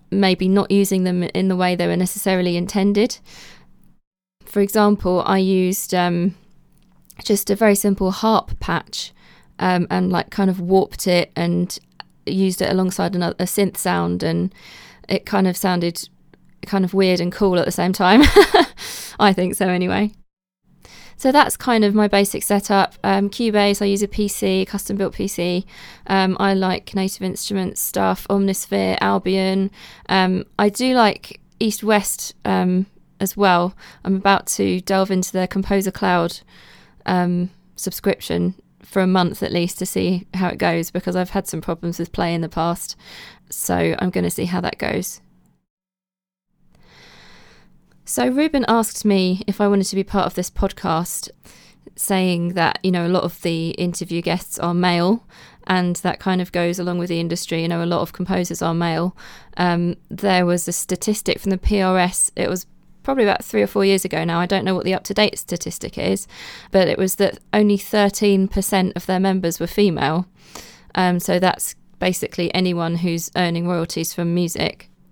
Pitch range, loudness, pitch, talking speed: 175-195 Hz, -19 LUFS, 185 Hz, 175 wpm